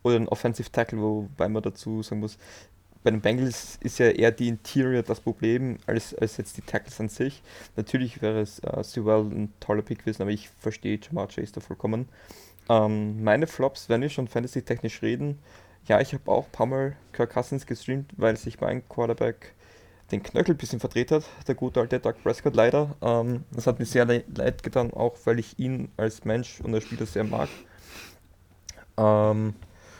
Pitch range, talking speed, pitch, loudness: 105-125 Hz, 190 wpm, 115 Hz, -27 LUFS